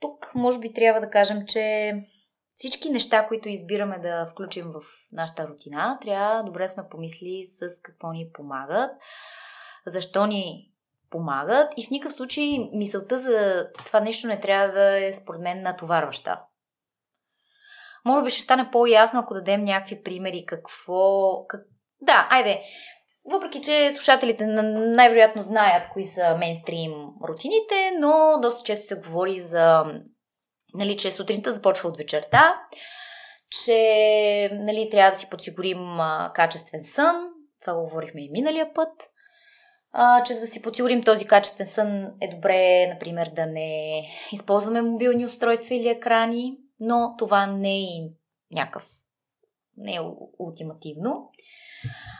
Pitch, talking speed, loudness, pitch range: 205 Hz, 135 wpm, -22 LUFS, 180-240 Hz